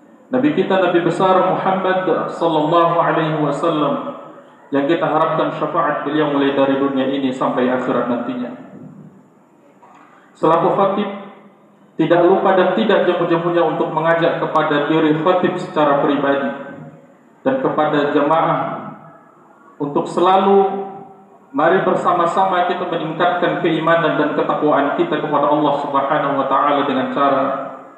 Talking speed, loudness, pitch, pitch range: 120 wpm, -17 LUFS, 165 Hz, 145-185 Hz